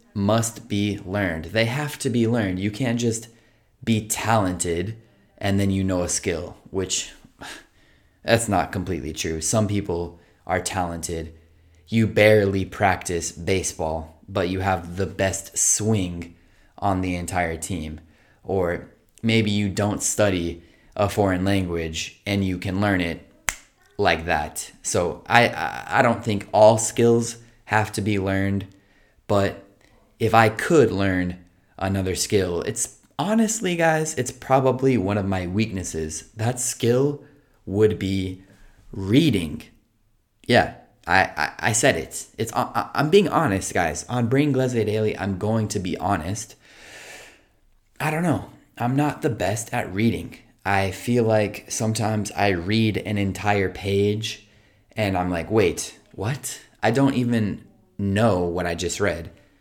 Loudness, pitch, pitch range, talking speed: -23 LUFS, 100 Hz, 95-115 Hz, 140 wpm